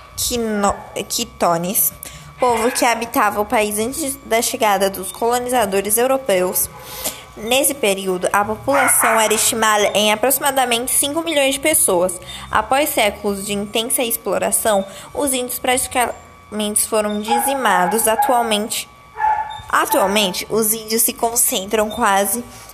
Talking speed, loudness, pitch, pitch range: 110 wpm, -17 LUFS, 225 Hz, 205-255 Hz